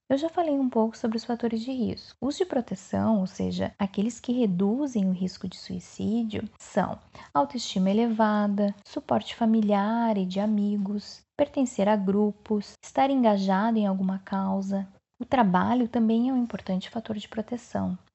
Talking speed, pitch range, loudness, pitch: 155 wpm, 195-240 Hz, -27 LUFS, 215 Hz